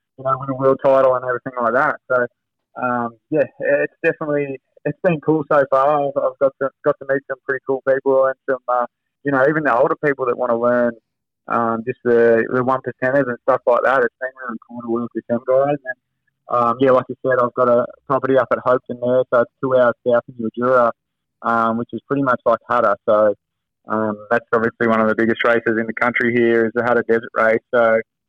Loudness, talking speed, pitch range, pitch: -18 LUFS, 235 wpm, 115-135 Hz, 125 Hz